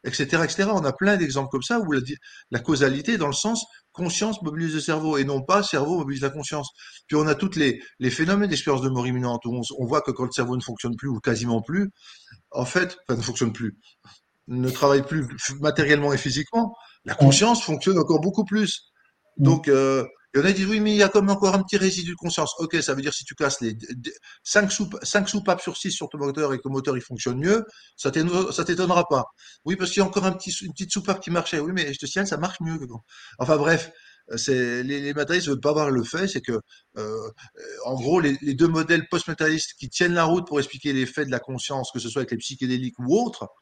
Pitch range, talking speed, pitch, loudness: 135-185 Hz, 250 wpm, 150 Hz, -23 LUFS